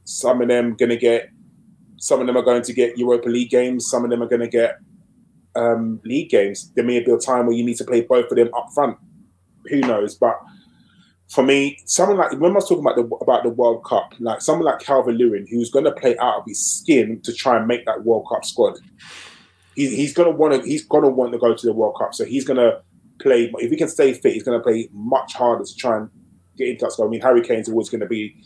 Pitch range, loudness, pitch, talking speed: 120-180 Hz, -19 LUFS, 125 Hz, 255 wpm